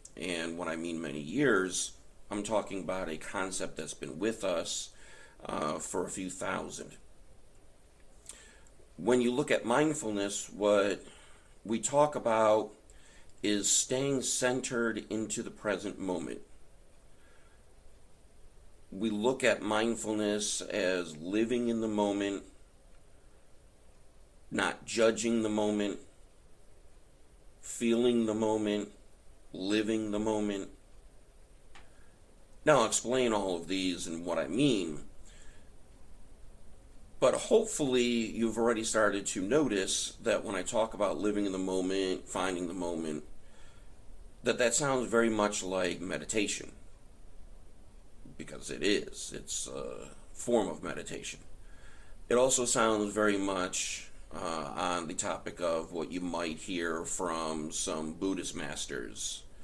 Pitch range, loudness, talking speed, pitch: 90-110 Hz, -32 LUFS, 120 wpm, 105 Hz